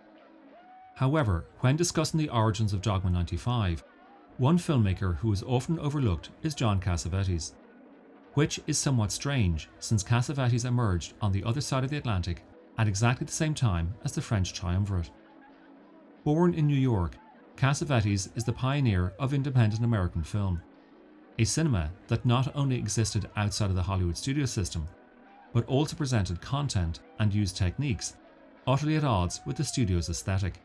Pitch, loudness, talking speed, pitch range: 115 Hz, -29 LUFS, 155 wpm, 95-140 Hz